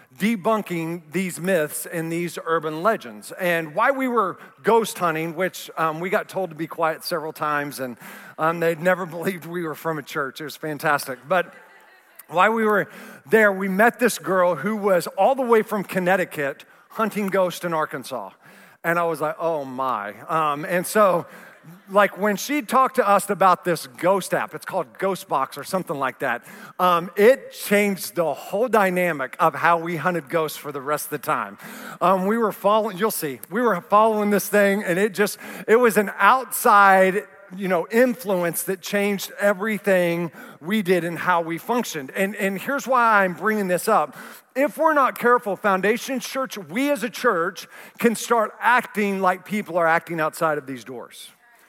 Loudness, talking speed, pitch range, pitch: -22 LUFS, 185 wpm, 165-215 Hz, 190 Hz